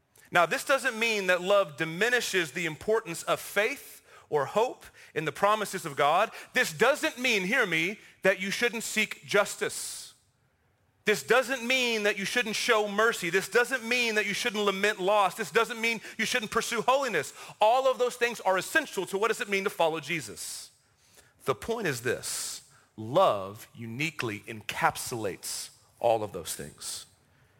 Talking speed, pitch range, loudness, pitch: 165 wpm, 185-240 Hz, -28 LUFS, 210 Hz